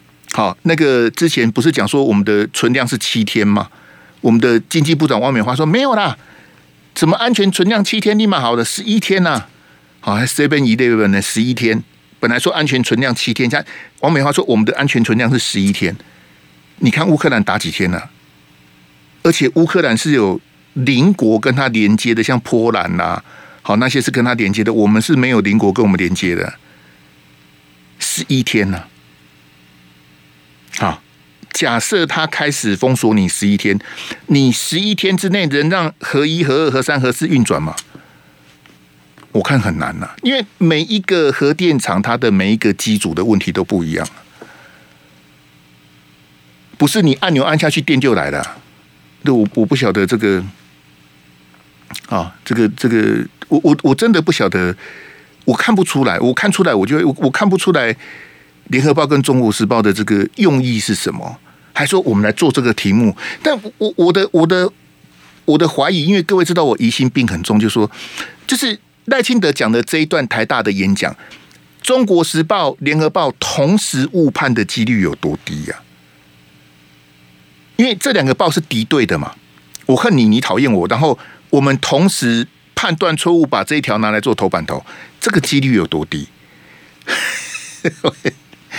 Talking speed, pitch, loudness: 255 characters per minute, 120 Hz, -14 LUFS